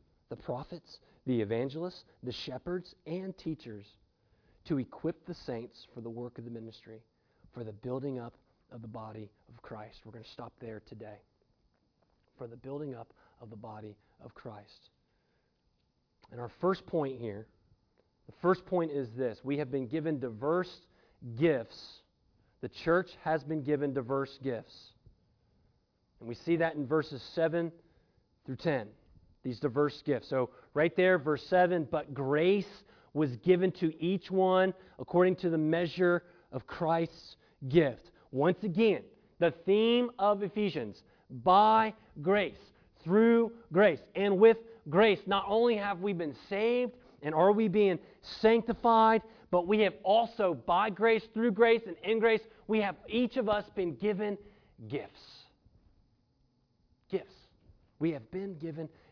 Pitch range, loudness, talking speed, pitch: 125-195 Hz, -31 LUFS, 145 wpm, 160 Hz